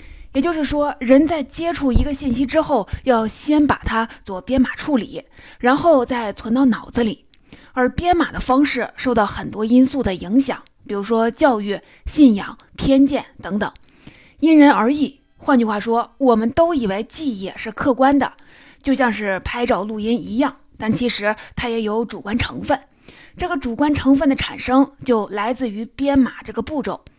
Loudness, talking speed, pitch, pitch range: -19 LUFS, 250 characters per minute, 250 Hz, 225-280 Hz